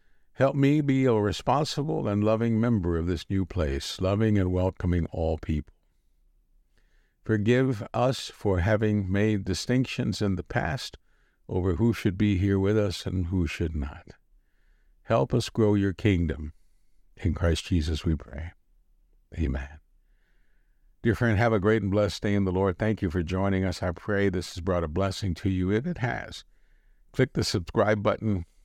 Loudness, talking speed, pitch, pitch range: -27 LUFS, 170 wpm, 95 Hz, 85-110 Hz